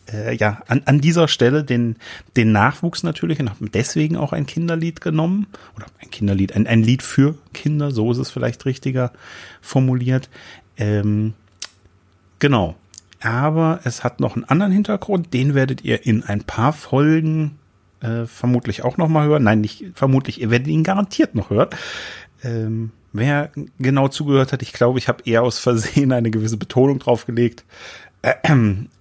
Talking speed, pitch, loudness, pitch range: 155 wpm, 125 Hz, -19 LUFS, 110-150 Hz